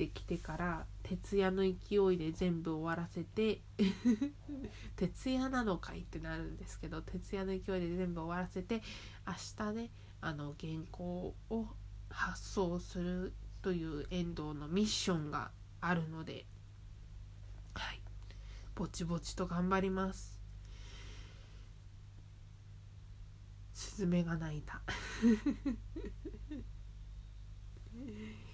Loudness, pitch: -39 LUFS, 160 Hz